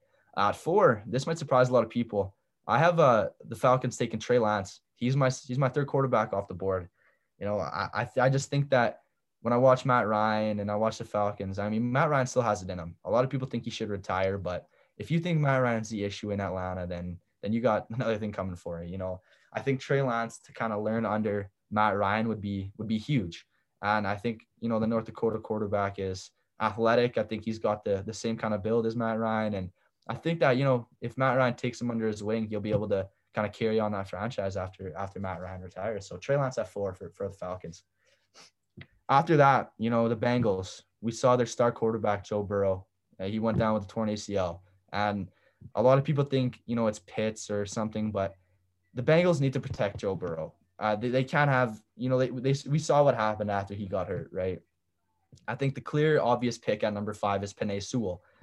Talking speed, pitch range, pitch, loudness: 240 wpm, 100-125 Hz, 110 Hz, -29 LUFS